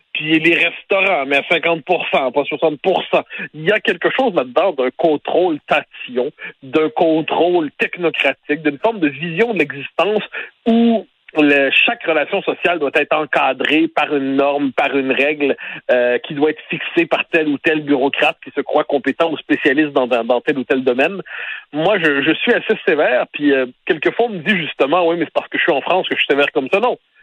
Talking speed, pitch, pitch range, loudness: 205 wpm, 155 Hz, 145-180 Hz, -16 LUFS